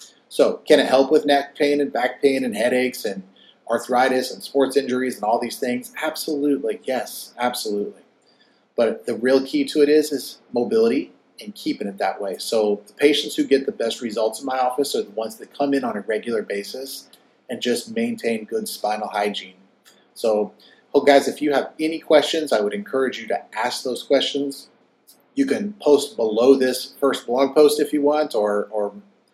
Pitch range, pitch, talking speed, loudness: 115-145 Hz, 135 Hz, 195 wpm, -21 LUFS